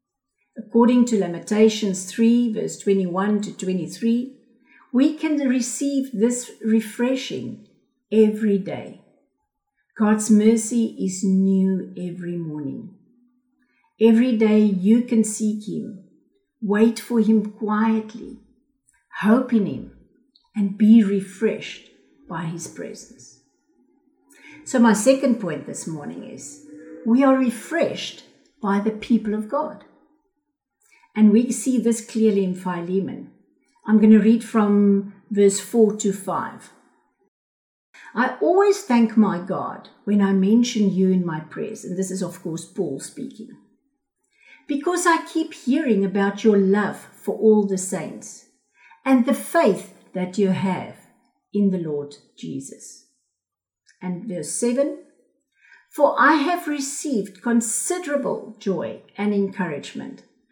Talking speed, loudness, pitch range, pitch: 120 wpm, -21 LUFS, 195-260 Hz, 220 Hz